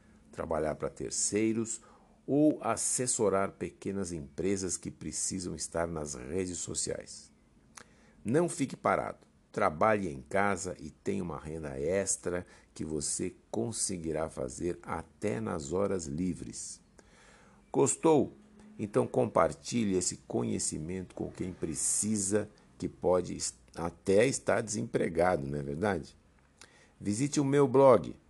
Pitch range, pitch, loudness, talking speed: 85-110 Hz, 95 Hz, -32 LUFS, 110 wpm